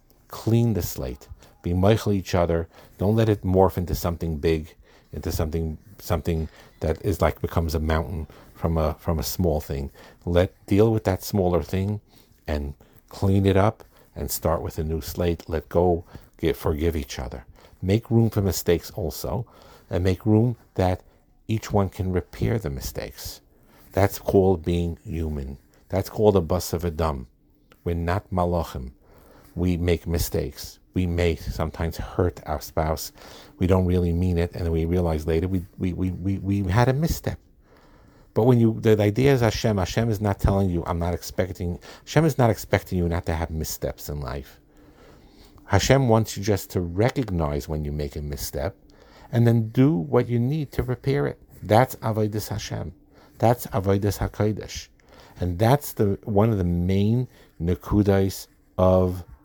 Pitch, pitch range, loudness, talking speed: 90 Hz, 80-105 Hz, -24 LUFS, 170 wpm